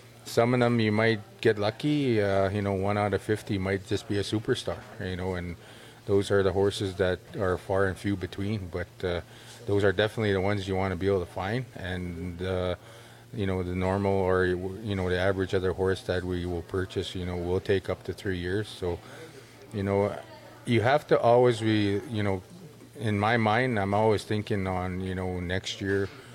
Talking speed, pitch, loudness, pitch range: 210 wpm, 100 Hz, -28 LUFS, 95-110 Hz